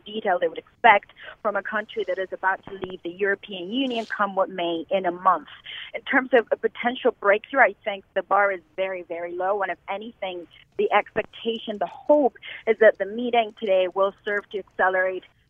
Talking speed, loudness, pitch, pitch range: 195 wpm, -24 LUFS, 200 Hz, 185-220 Hz